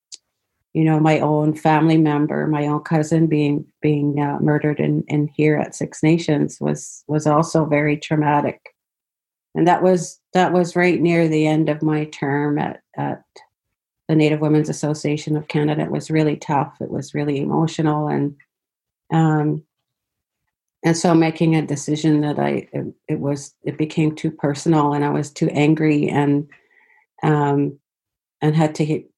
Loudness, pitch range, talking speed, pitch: -19 LUFS, 145-160 Hz, 160 wpm, 150 Hz